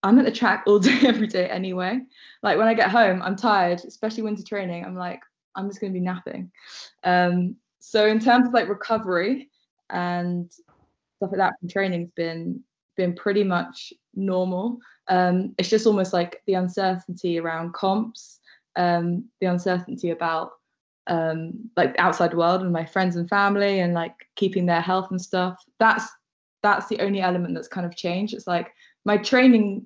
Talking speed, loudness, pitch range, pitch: 175 wpm, -23 LUFS, 175-215 Hz, 190 Hz